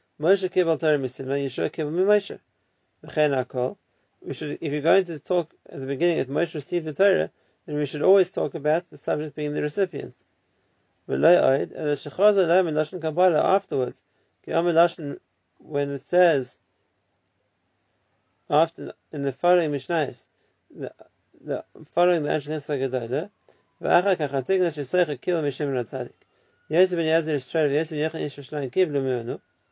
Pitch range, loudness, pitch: 135-170 Hz, -24 LUFS, 150 Hz